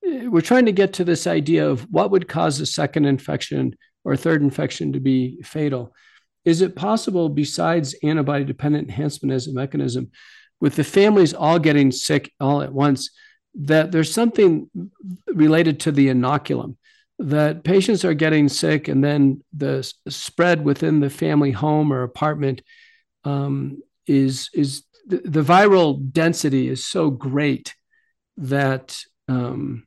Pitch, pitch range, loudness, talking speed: 150 Hz, 140-180 Hz, -19 LUFS, 150 wpm